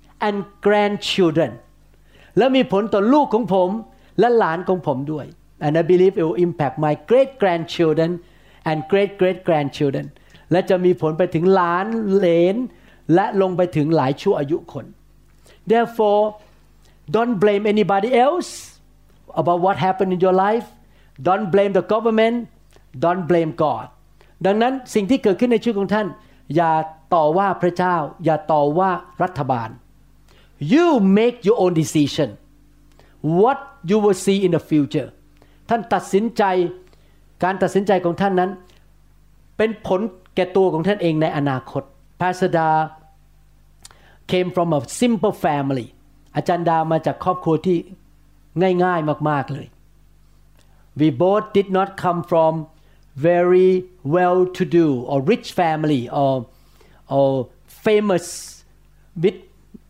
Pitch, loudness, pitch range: 175 Hz, -19 LUFS, 150-195 Hz